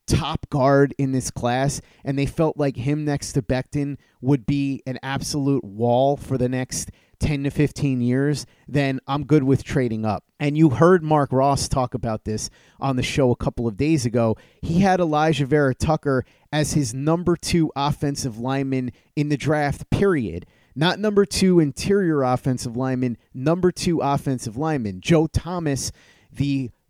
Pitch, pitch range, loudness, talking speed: 140 Hz, 130-150 Hz, -22 LUFS, 165 wpm